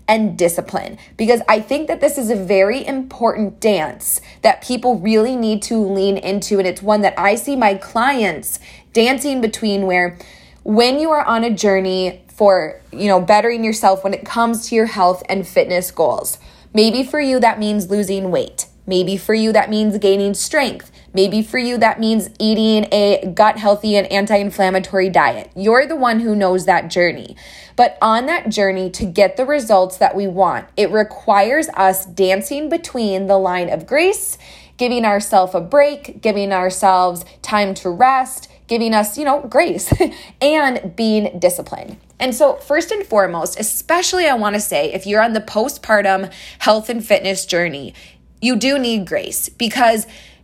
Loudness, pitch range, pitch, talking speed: -16 LUFS, 195-240 Hz, 210 Hz, 170 wpm